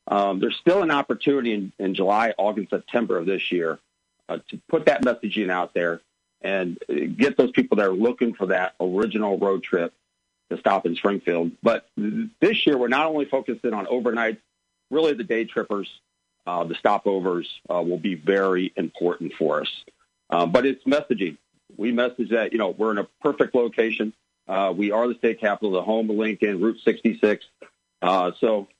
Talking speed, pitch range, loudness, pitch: 185 wpm, 95-120 Hz, -23 LUFS, 110 Hz